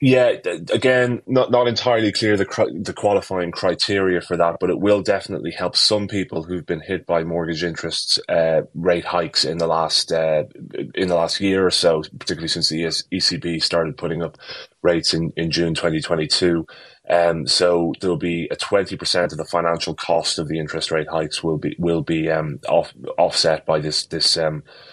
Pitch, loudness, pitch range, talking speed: 85 Hz, -20 LUFS, 80-95 Hz, 185 wpm